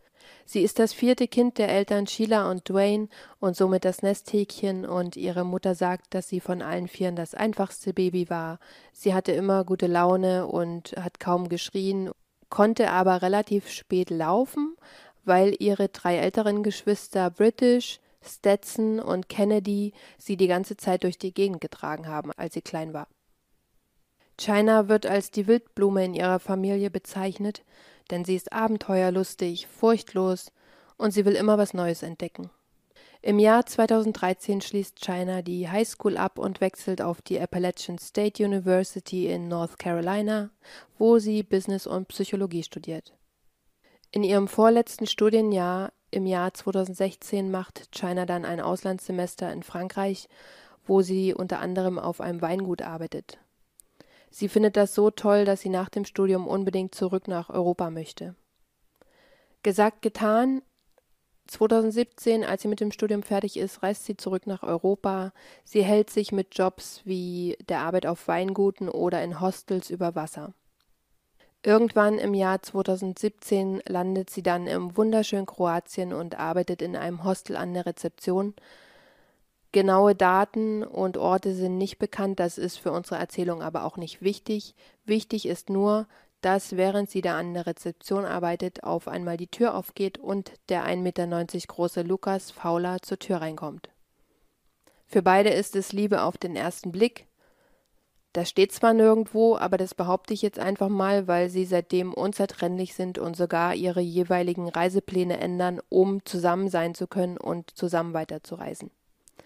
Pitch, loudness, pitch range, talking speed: 190 Hz, -26 LUFS, 180-205 Hz, 150 wpm